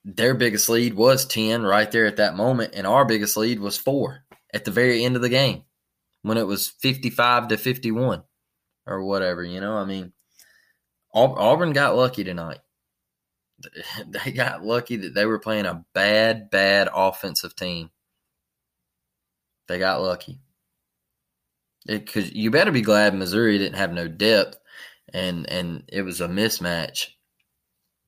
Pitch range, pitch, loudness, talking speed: 85-110 Hz, 100 Hz, -22 LUFS, 150 wpm